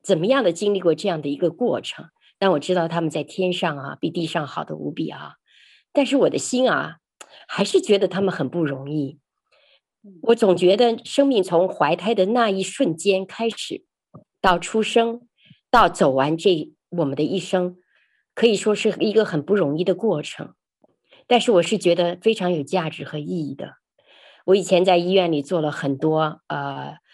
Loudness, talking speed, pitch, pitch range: -21 LUFS, 255 characters per minute, 185 Hz, 165-220 Hz